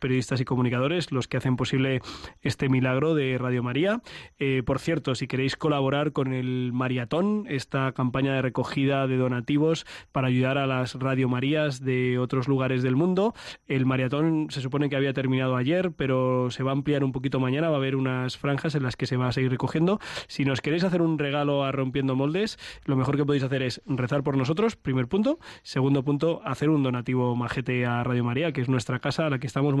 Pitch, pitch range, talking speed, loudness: 135 Hz, 130-145 Hz, 210 wpm, -26 LUFS